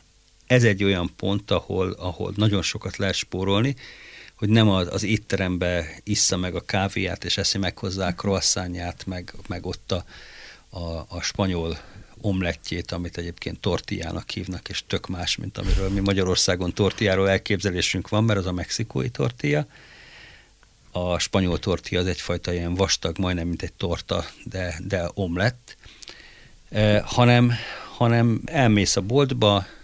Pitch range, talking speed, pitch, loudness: 90-105 Hz, 145 wpm, 95 Hz, -24 LUFS